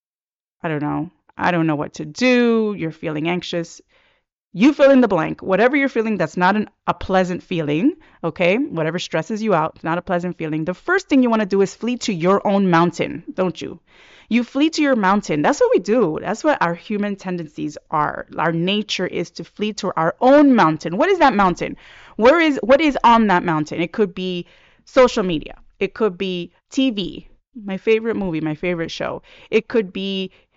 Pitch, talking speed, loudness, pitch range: 190 Hz, 205 wpm, -19 LUFS, 170-235 Hz